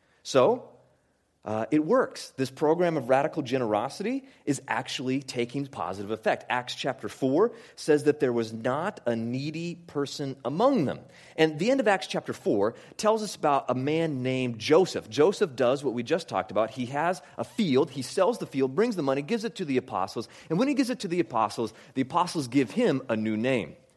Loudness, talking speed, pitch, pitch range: -27 LUFS, 200 wpm, 145 Hz, 125-180 Hz